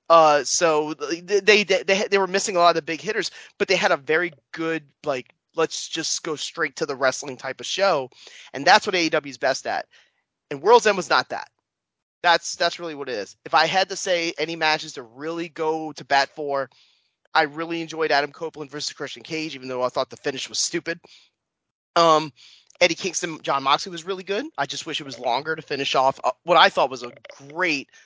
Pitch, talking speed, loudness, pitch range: 160 Hz, 215 wpm, -22 LUFS, 140-170 Hz